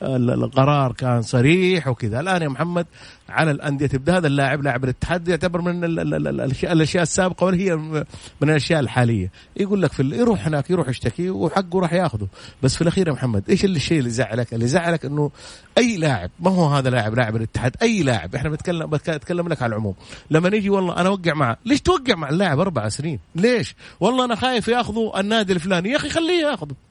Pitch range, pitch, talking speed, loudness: 130-185 Hz, 160 Hz, 190 wpm, -20 LUFS